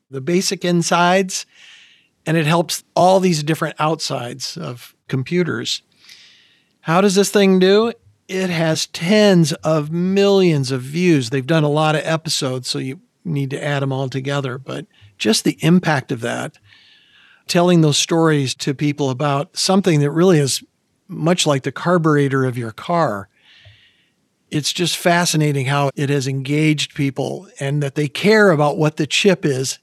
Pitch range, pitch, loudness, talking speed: 140-175 Hz, 155 Hz, -17 LUFS, 155 wpm